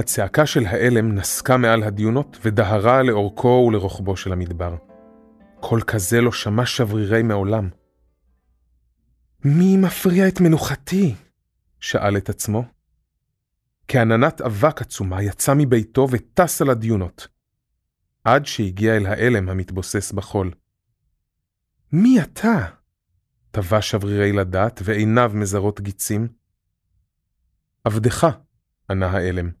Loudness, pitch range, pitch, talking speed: -19 LUFS, 95-125 Hz, 110 Hz, 100 wpm